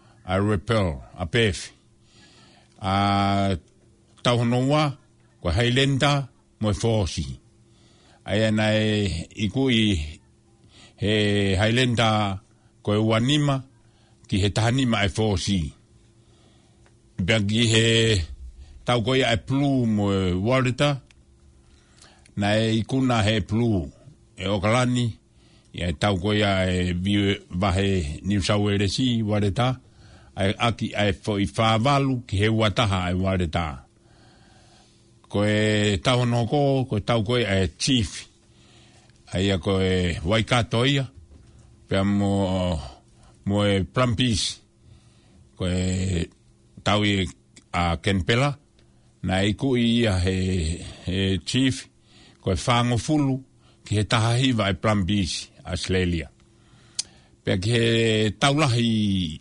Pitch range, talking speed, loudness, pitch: 95-115 Hz, 100 wpm, -23 LUFS, 110 Hz